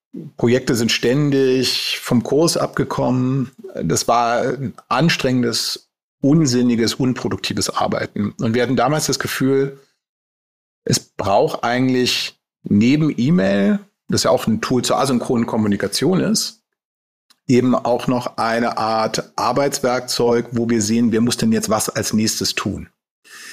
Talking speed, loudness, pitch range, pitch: 125 wpm, -18 LUFS, 120-140 Hz, 125 Hz